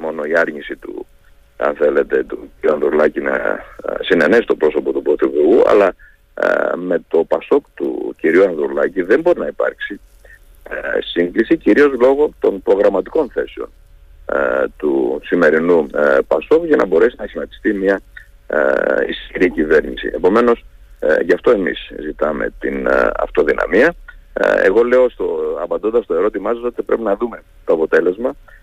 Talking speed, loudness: 130 wpm, -16 LUFS